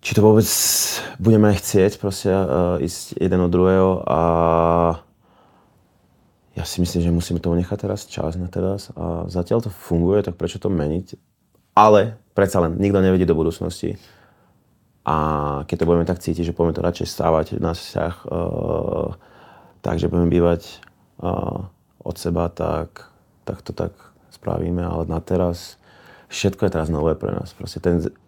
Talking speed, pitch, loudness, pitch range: 155 wpm, 90 Hz, -20 LUFS, 85-95 Hz